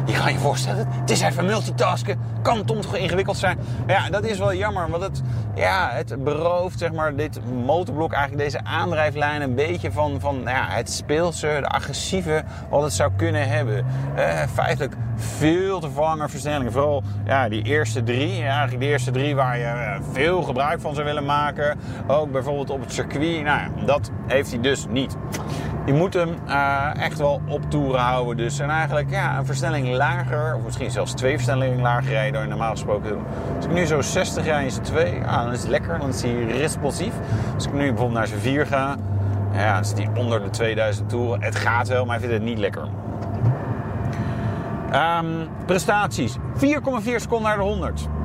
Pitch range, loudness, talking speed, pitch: 115-145 Hz, -23 LUFS, 200 wpm, 130 Hz